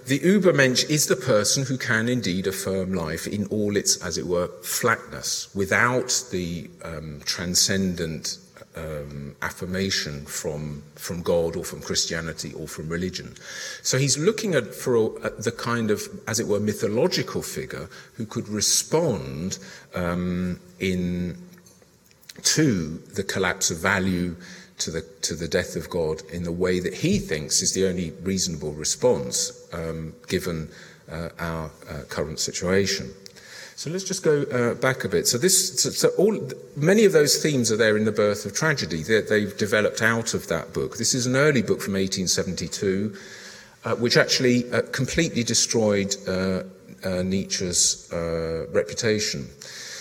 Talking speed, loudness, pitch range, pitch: 155 wpm, -23 LUFS, 90-120 Hz, 95 Hz